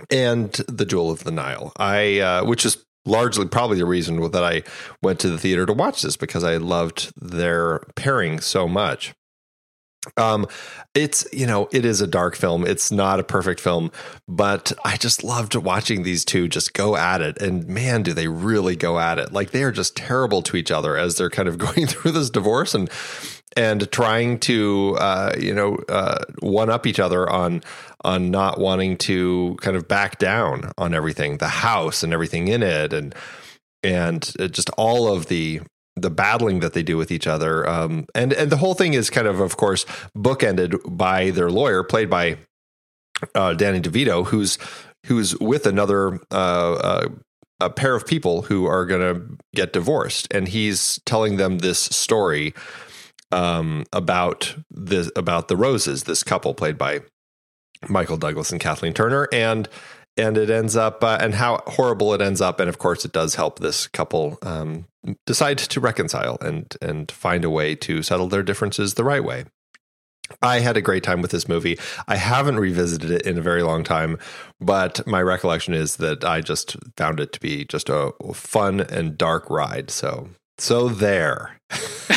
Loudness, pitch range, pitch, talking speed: -21 LUFS, 85-110 Hz, 95 Hz, 185 wpm